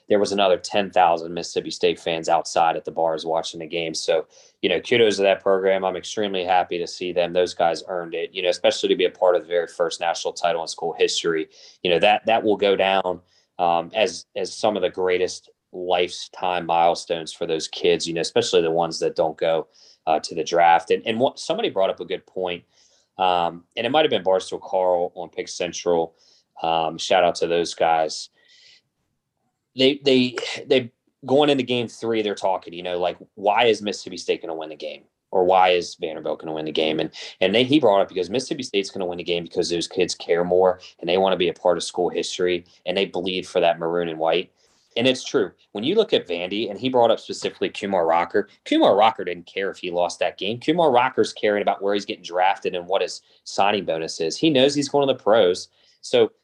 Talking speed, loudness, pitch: 230 wpm, -22 LUFS, 100 Hz